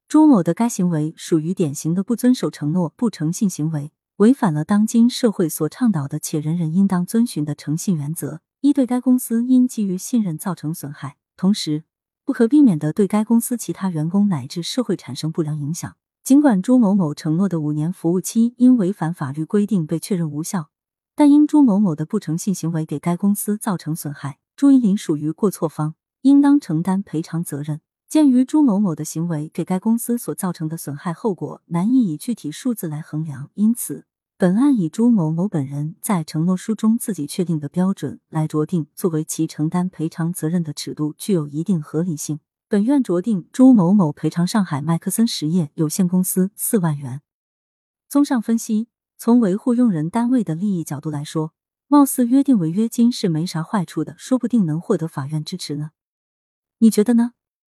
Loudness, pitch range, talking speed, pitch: -19 LUFS, 155-230 Hz, 295 characters per minute, 180 Hz